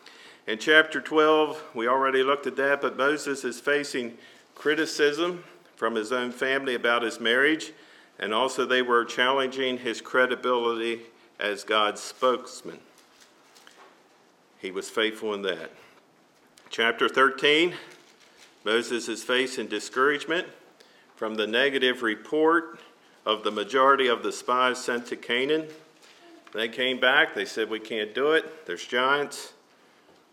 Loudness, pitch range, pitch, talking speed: -25 LUFS, 115-145 Hz, 125 Hz, 130 wpm